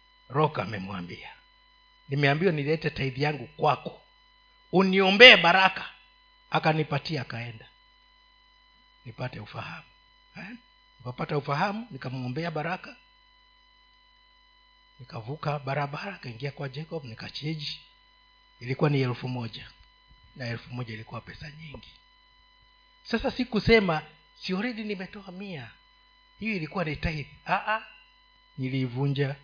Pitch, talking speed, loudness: 185 Hz, 90 wpm, -25 LUFS